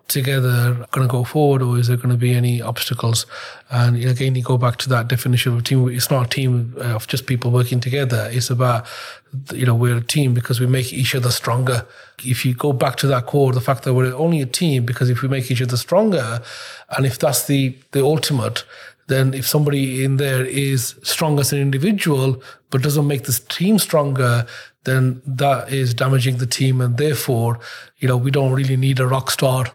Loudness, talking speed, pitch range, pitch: -18 LUFS, 210 wpm, 125-135 Hz, 130 Hz